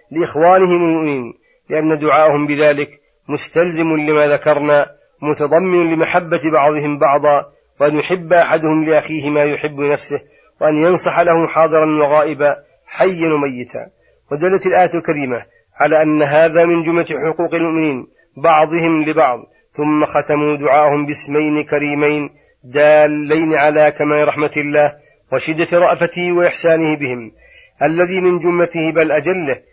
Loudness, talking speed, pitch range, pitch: -14 LUFS, 115 wpm, 145-165 Hz, 155 Hz